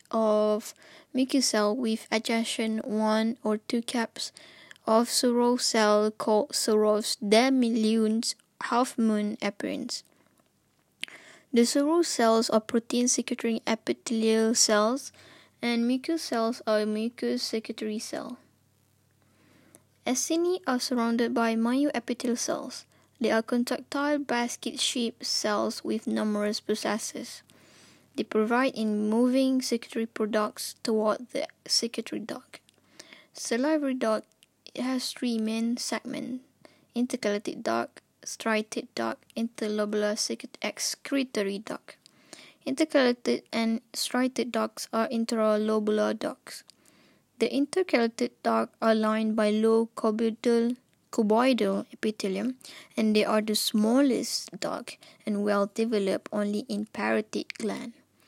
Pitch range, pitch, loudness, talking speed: 215-255 Hz, 230 Hz, -27 LUFS, 105 wpm